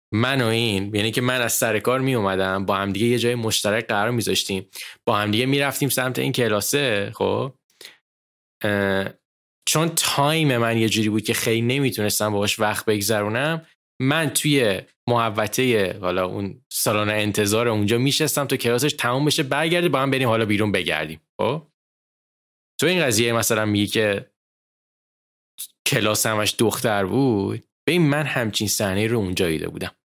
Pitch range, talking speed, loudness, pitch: 105-130 Hz, 160 wpm, -21 LUFS, 115 Hz